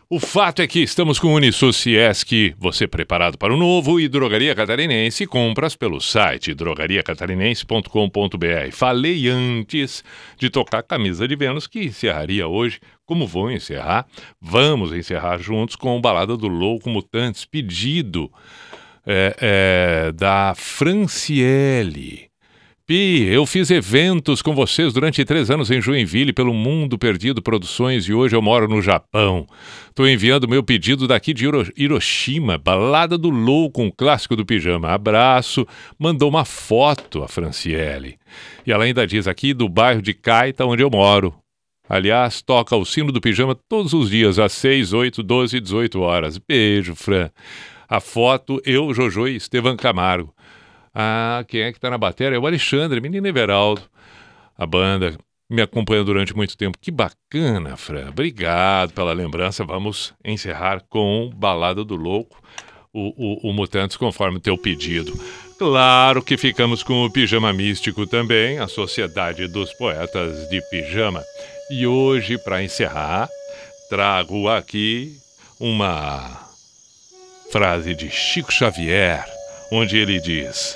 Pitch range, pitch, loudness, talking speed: 100-135 Hz, 115 Hz, -18 LUFS, 145 wpm